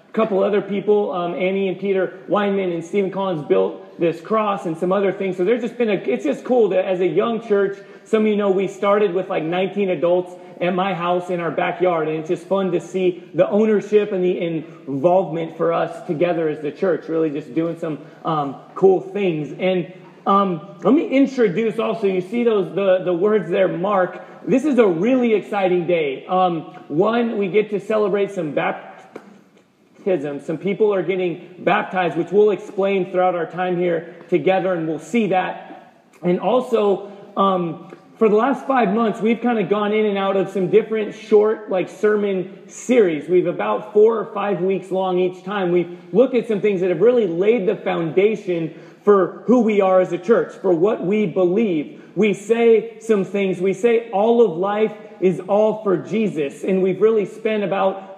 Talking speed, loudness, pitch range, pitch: 195 wpm, -19 LUFS, 180-210 Hz, 190 Hz